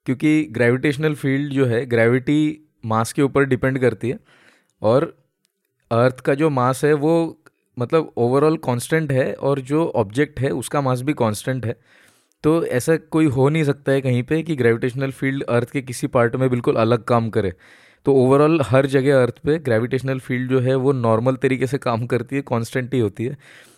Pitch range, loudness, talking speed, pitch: 120-150 Hz, -19 LUFS, 185 wpm, 135 Hz